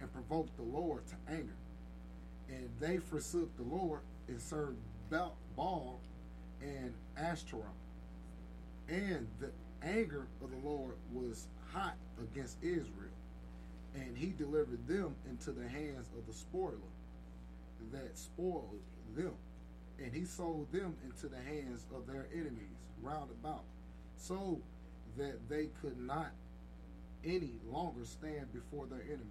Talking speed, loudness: 125 wpm, -44 LUFS